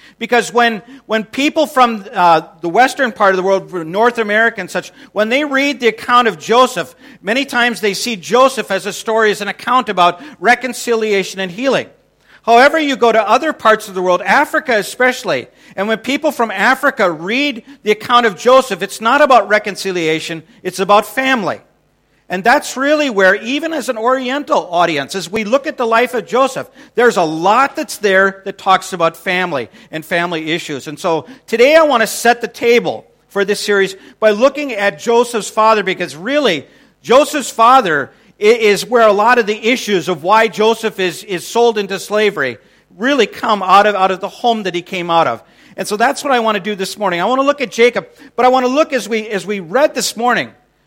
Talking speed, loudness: 205 wpm, -14 LUFS